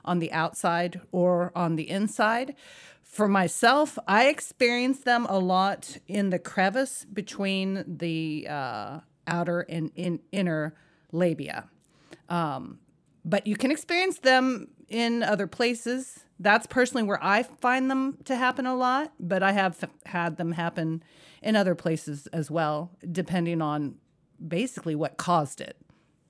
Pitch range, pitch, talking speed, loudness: 170-235 Hz, 190 Hz, 140 wpm, -27 LUFS